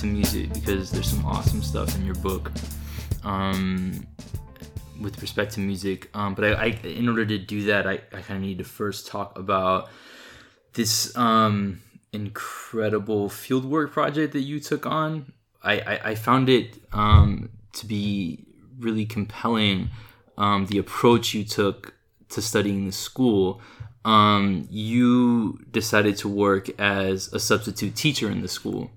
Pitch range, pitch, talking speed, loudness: 95-115 Hz, 105 Hz, 145 wpm, -24 LUFS